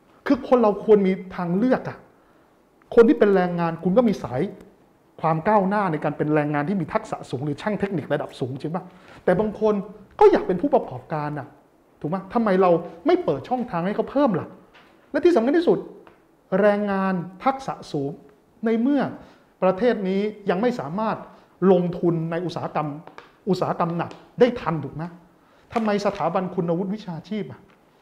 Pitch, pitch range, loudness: 190 Hz, 165-215 Hz, -23 LUFS